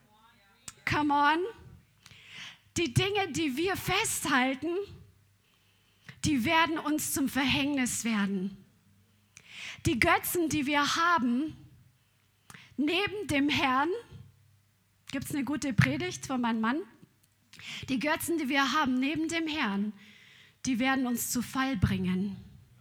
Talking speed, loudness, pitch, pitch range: 115 wpm, -29 LUFS, 275 Hz, 225-310 Hz